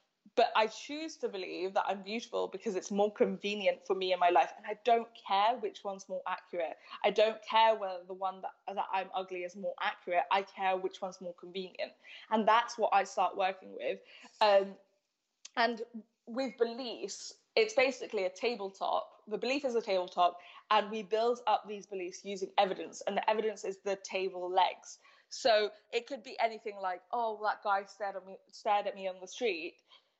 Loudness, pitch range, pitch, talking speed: -33 LUFS, 190-230 Hz, 205 Hz, 210 wpm